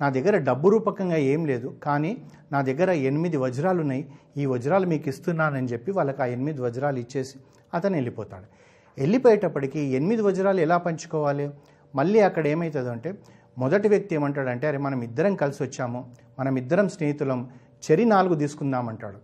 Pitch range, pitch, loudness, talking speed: 130-170 Hz, 145 Hz, -24 LUFS, 140 wpm